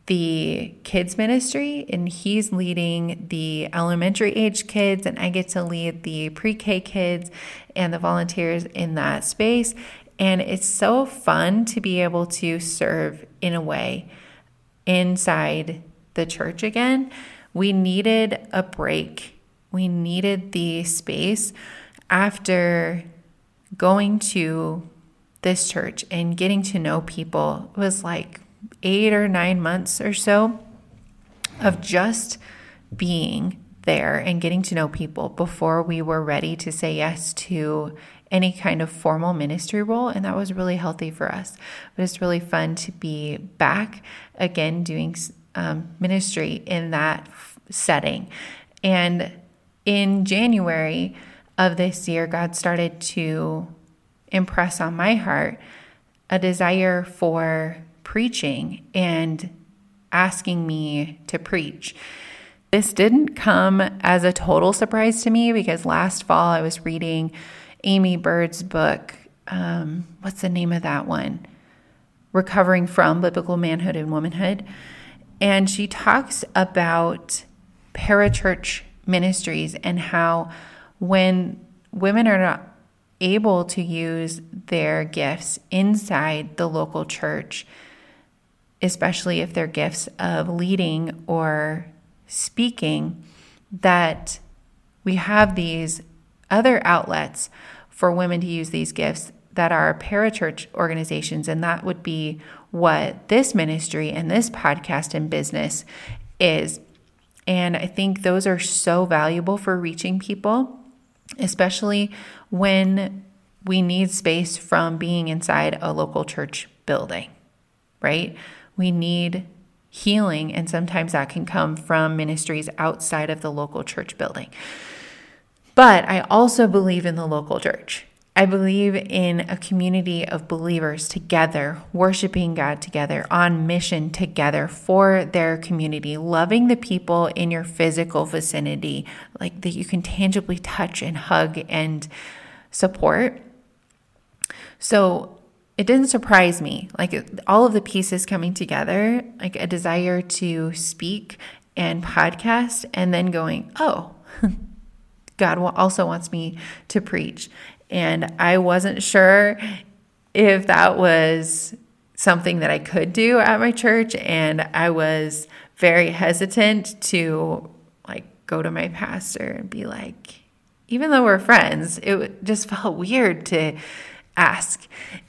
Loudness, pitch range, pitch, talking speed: -21 LUFS, 165-195 Hz, 180 Hz, 125 wpm